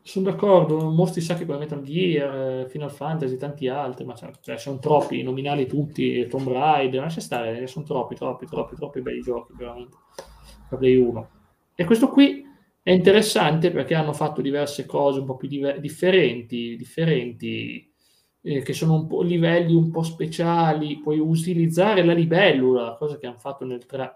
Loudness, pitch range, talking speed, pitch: -22 LUFS, 130-170 Hz, 170 wpm, 145 Hz